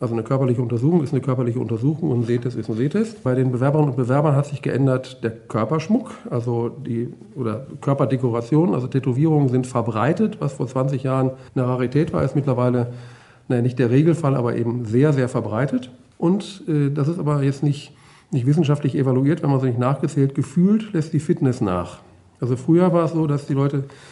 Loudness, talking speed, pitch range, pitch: -21 LUFS, 195 wpm, 125-150 Hz, 135 Hz